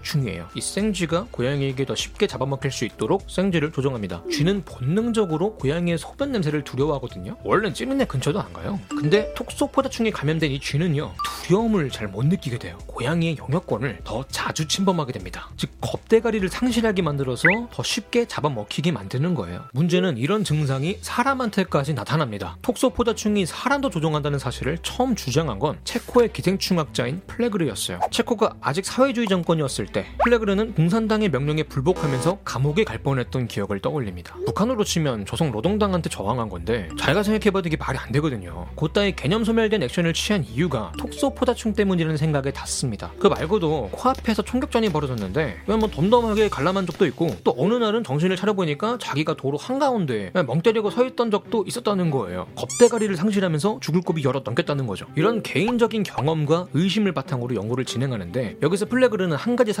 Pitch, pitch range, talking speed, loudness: 170 Hz, 135-215 Hz, 440 characters per minute, -23 LUFS